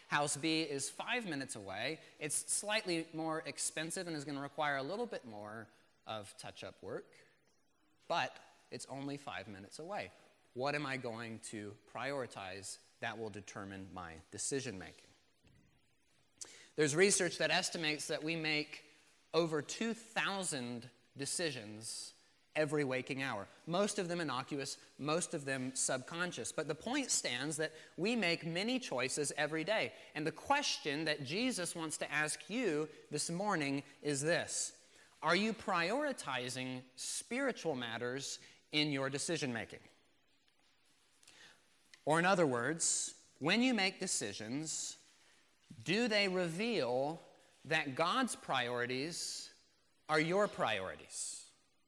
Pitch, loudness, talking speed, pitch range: 150 Hz, -37 LUFS, 130 wpm, 130-175 Hz